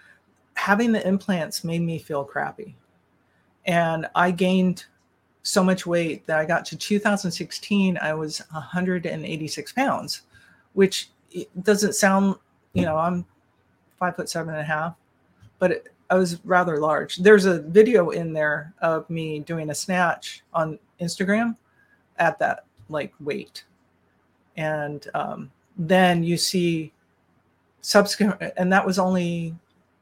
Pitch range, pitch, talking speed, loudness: 155-190 Hz, 170 Hz, 130 wpm, -23 LUFS